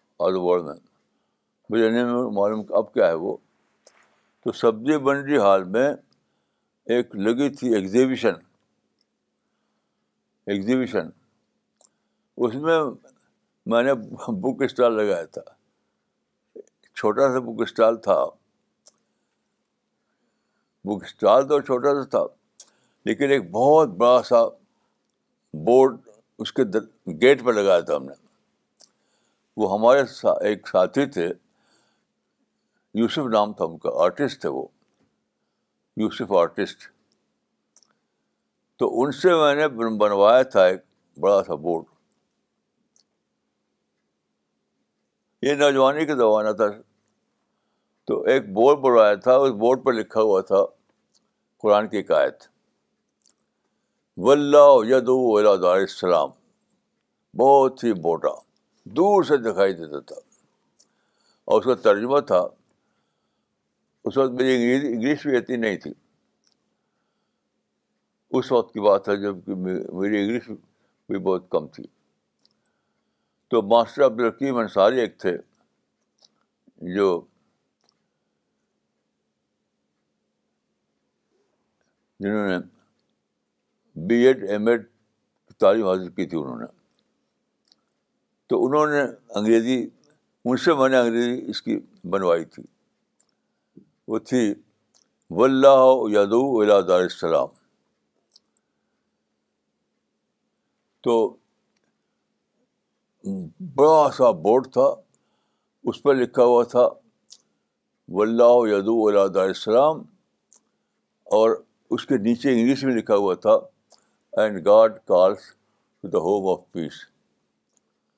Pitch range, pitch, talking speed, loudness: 105-140 Hz, 120 Hz, 105 wpm, -21 LUFS